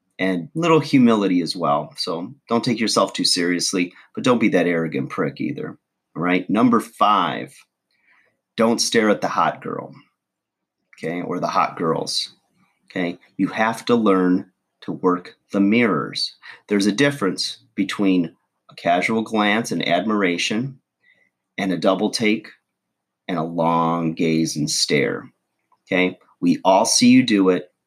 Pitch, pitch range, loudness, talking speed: 95 Hz, 90-110 Hz, -20 LUFS, 145 wpm